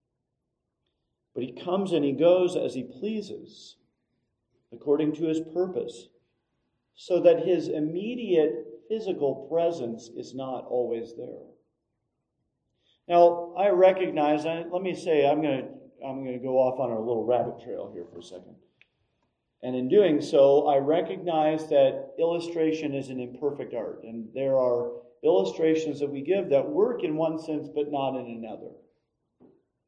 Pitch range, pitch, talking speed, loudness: 125-170 Hz, 150 Hz, 145 wpm, -26 LUFS